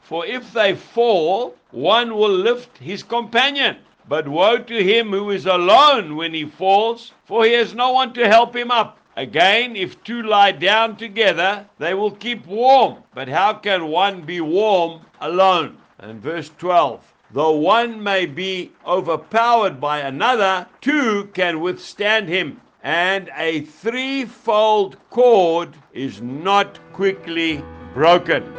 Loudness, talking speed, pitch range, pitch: -18 LUFS, 140 wpm, 175-230 Hz, 200 Hz